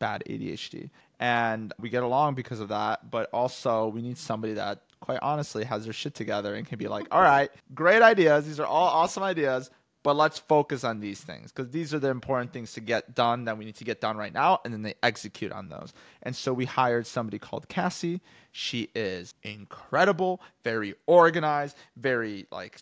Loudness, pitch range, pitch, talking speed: -27 LUFS, 110-150 Hz, 125 Hz, 205 wpm